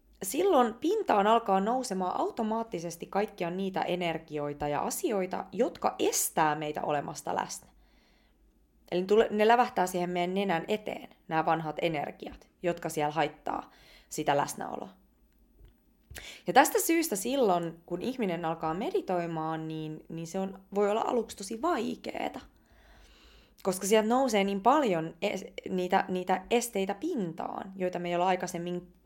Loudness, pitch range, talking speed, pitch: -30 LUFS, 170-225 Hz, 130 wpm, 190 Hz